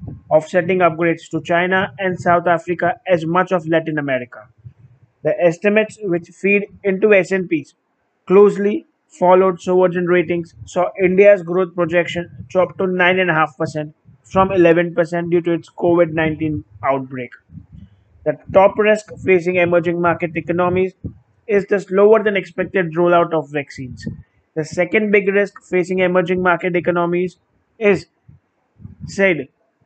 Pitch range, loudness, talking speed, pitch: 160-185 Hz, -17 LUFS, 140 wpm, 175 Hz